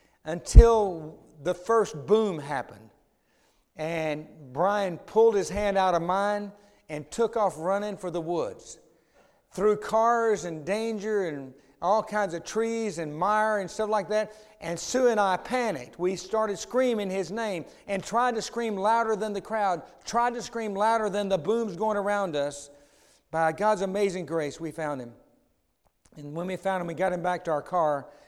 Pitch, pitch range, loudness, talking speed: 200 Hz, 165-220 Hz, -27 LUFS, 175 wpm